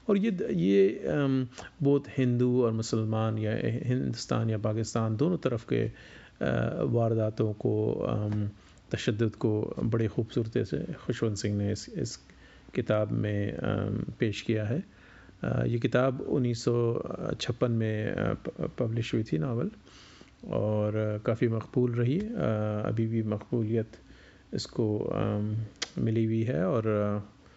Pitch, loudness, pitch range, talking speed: 115 Hz, -30 LUFS, 105-125 Hz, 110 wpm